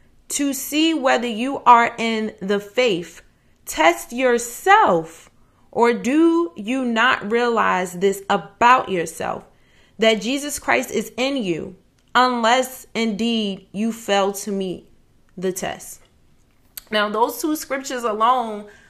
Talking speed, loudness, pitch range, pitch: 115 wpm, -20 LUFS, 200-260 Hz, 230 Hz